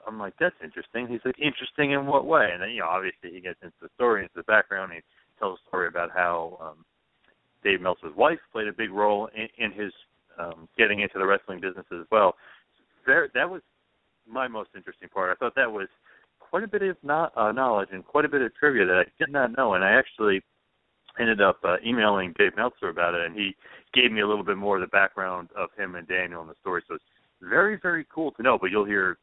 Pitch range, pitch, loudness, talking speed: 100-140 Hz, 110 Hz, -25 LUFS, 240 wpm